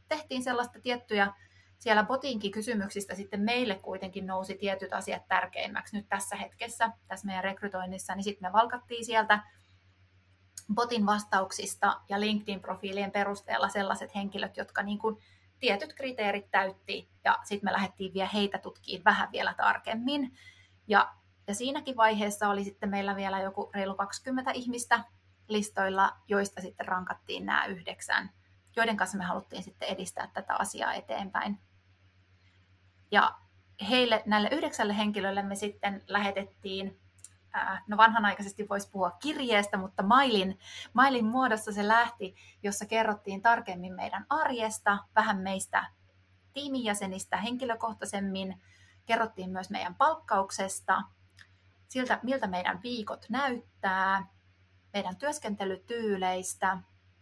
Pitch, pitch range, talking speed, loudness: 200 Hz, 185-220 Hz, 120 wpm, -31 LUFS